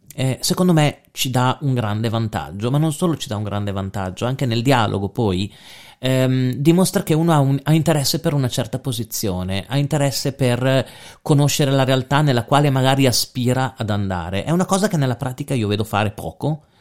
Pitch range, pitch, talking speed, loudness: 115-145 Hz, 130 Hz, 195 wpm, -19 LUFS